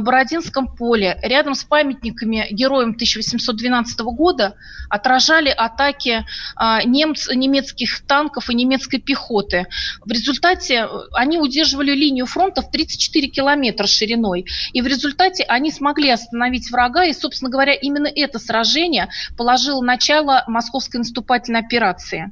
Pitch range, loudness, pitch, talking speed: 235-285 Hz, -17 LUFS, 255 Hz, 120 wpm